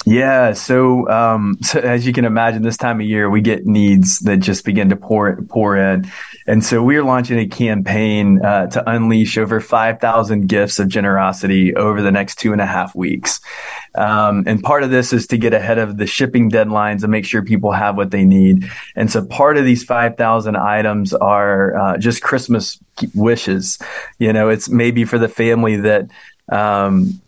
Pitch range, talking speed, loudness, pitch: 100-115 Hz, 195 wpm, -14 LUFS, 110 Hz